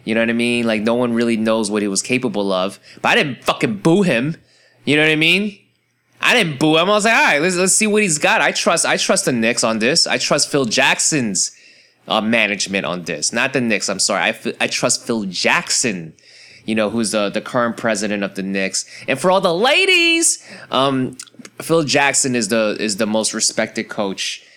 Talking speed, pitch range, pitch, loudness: 225 wpm, 110-165 Hz, 125 Hz, -16 LUFS